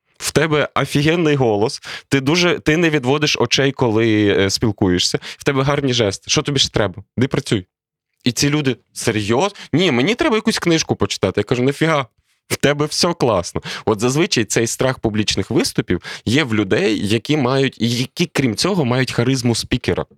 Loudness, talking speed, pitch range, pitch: -17 LUFS, 165 wpm, 110-150 Hz, 130 Hz